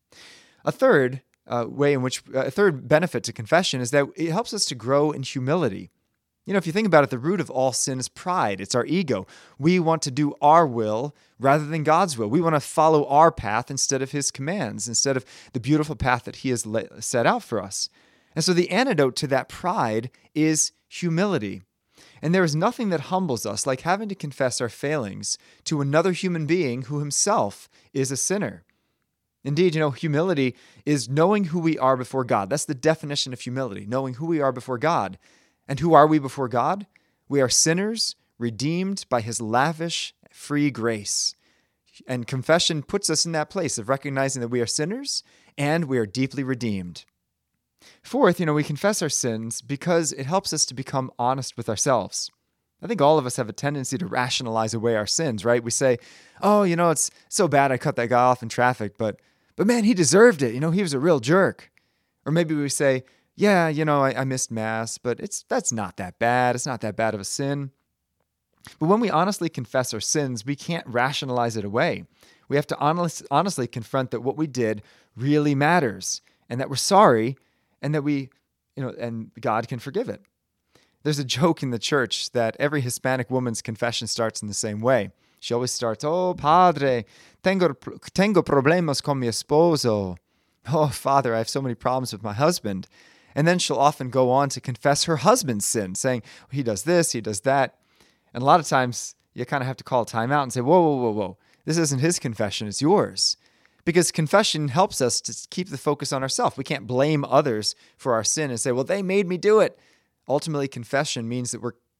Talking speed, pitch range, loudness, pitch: 205 wpm, 120-160 Hz, -23 LUFS, 135 Hz